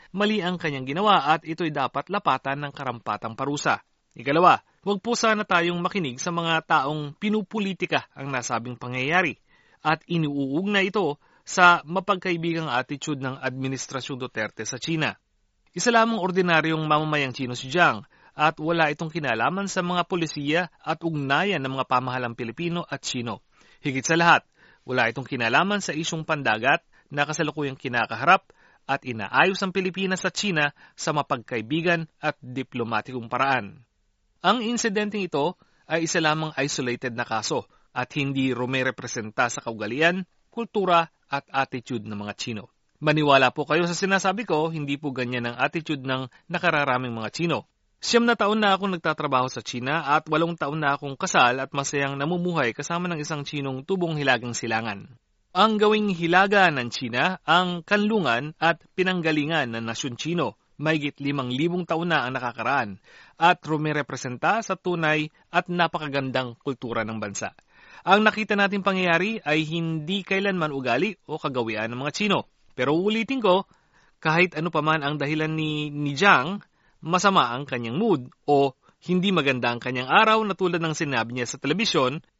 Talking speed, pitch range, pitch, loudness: 155 wpm, 130-180 Hz, 155 Hz, -24 LUFS